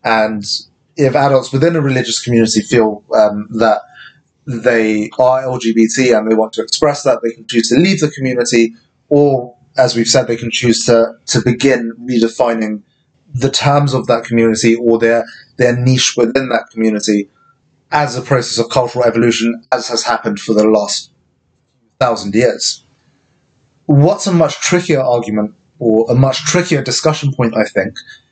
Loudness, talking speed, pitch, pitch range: -13 LUFS, 160 wpm, 120 Hz, 115-135 Hz